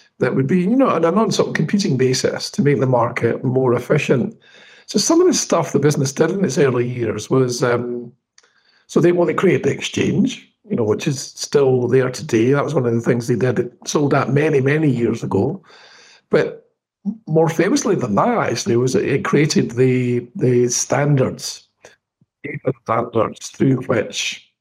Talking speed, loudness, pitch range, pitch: 185 wpm, -18 LUFS, 125-165 Hz, 135 Hz